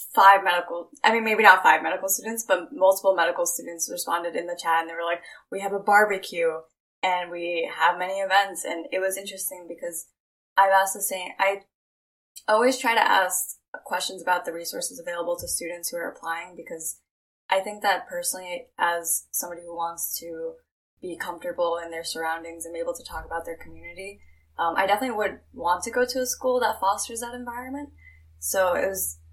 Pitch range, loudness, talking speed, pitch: 170-200 Hz, -24 LUFS, 190 wpm, 180 Hz